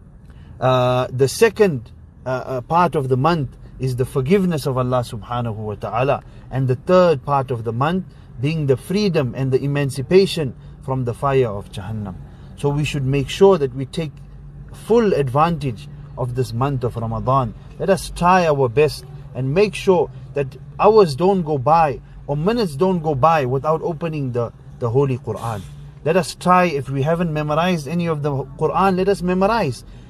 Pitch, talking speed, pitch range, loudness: 140 Hz, 175 wpm, 130-165 Hz, -19 LUFS